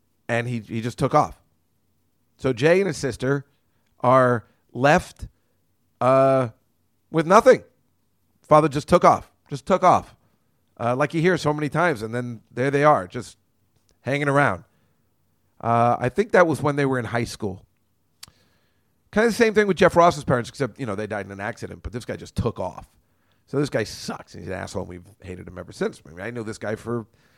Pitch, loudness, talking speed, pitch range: 120 Hz, -21 LUFS, 205 wpm, 105-145 Hz